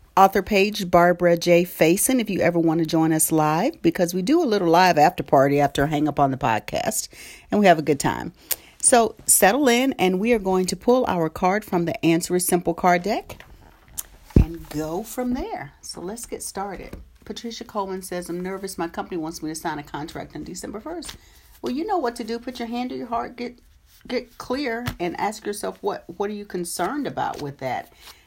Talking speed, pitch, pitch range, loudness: 215 wpm, 185 Hz, 165-230 Hz, -22 LUFS